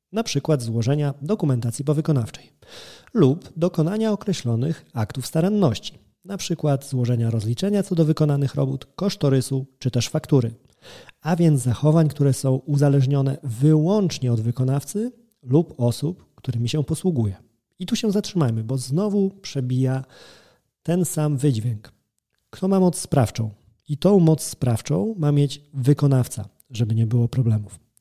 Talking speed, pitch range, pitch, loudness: 130 wpm, 125-165 Hz, 140 Hz, -22 LUFS